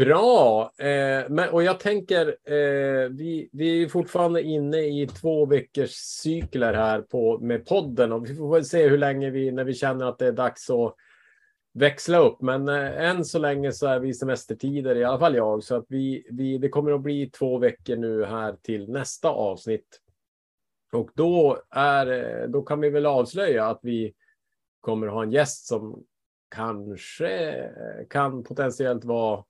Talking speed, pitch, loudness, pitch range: 175 wpm, 135 Hz, -24 LUFS, 120-150 Hz